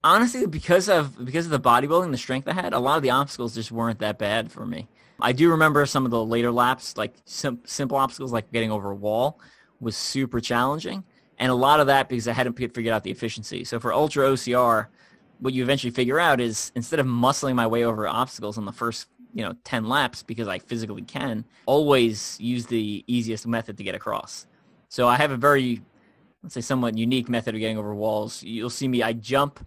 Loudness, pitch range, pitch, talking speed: -24 LUFS, 115-135 Hz, 120 Hz, 220 wpm